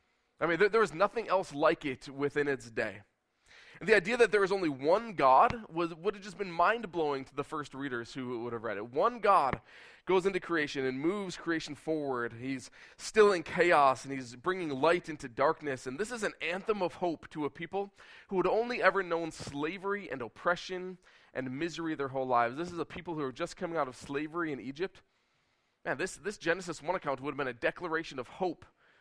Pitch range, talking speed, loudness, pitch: 140-185 Hz, 215 wpm, -32 LUFS, 165 Hz